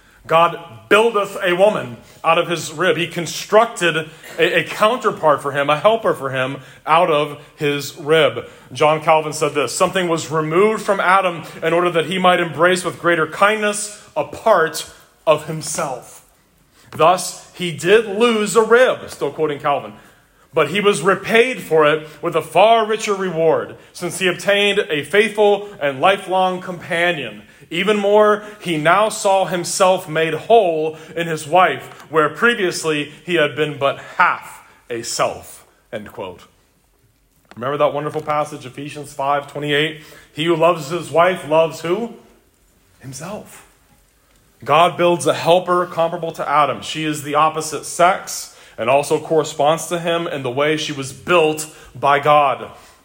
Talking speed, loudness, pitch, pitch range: 155 wpm, -17 LUFS, 165 Hz, 150-185 Hz